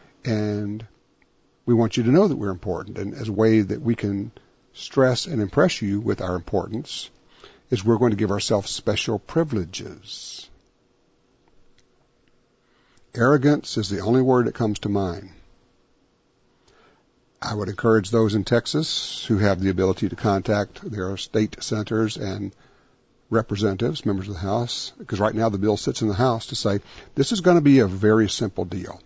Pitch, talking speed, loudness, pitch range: 110 Hz, 165 wpm, -22 LUFS, 100-120 Hz